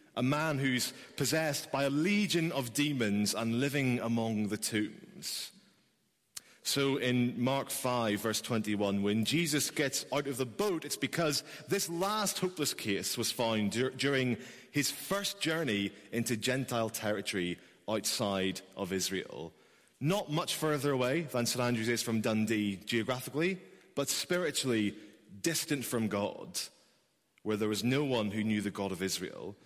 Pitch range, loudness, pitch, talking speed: 110-145 Hz, -33 LUFS, 125 Hz, 150 wpm